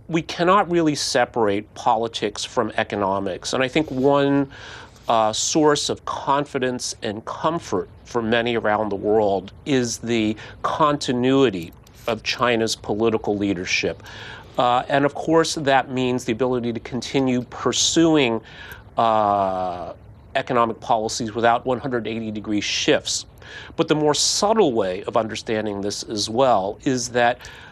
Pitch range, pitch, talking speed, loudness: 110-135 Hz, 120 Hz, 130 wpm, -21 LUFS